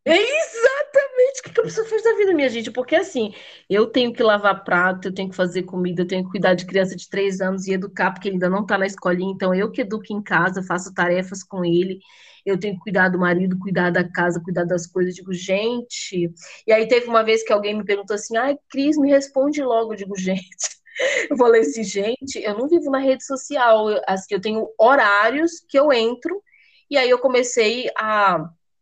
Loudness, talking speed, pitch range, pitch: -20 LUFS, 220 wpm, 185-260 Hz, 210 Hz